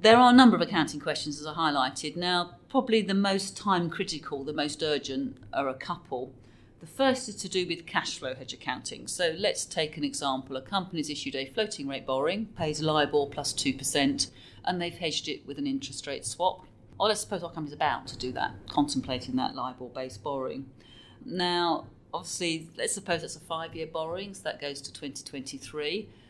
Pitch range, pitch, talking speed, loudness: 135-175 Hz, 150 Hz, 195 wpm, -29 LUFS